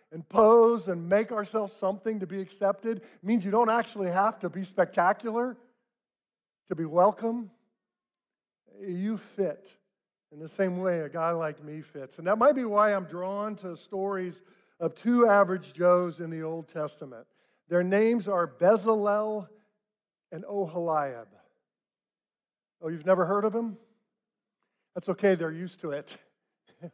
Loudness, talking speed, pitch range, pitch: -27 LUFS, 150 wpm, 175-220 Hz, 195 Hz